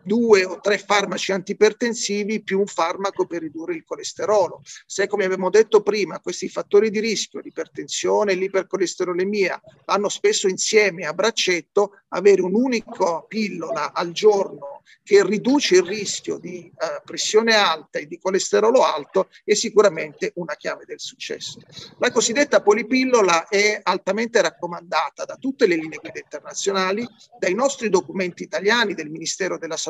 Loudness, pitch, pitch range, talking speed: -20 LUFS, 205 Hz, 185-235 Hz, 145 wpm